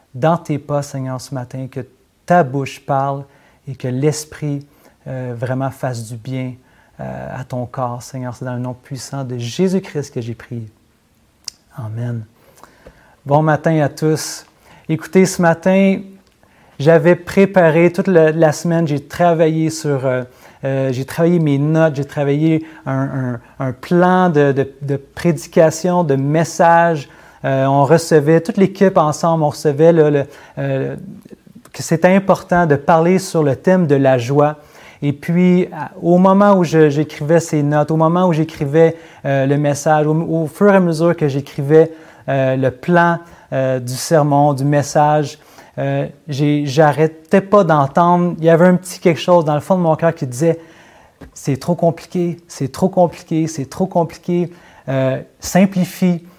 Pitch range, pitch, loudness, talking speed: 135-170 Hz, 150 Hz, -15 LUFS, 160 wpm